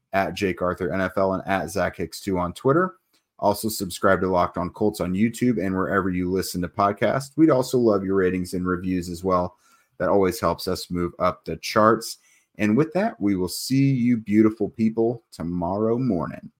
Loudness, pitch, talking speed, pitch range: -23 LUFS, 95 Hz, 175 wpm, 90-110 Hz